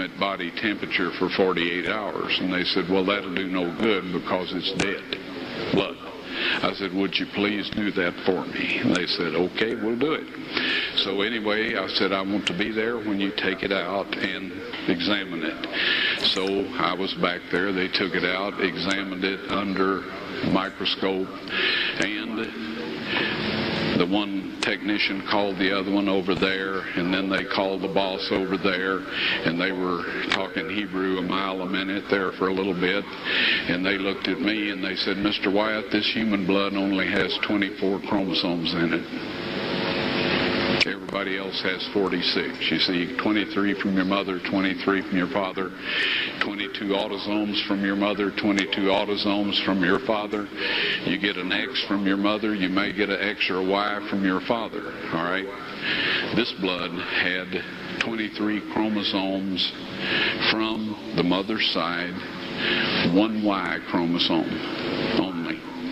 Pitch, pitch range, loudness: 95 Hz, 95-100 Hz, -24 LUFS